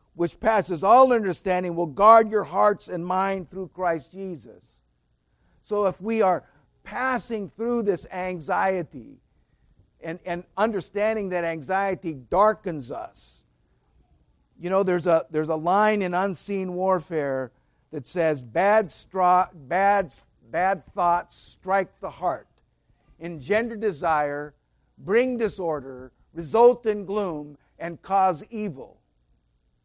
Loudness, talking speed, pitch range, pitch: -24 LUFS, 115 wpm, 155-200 Hz, 180 Hz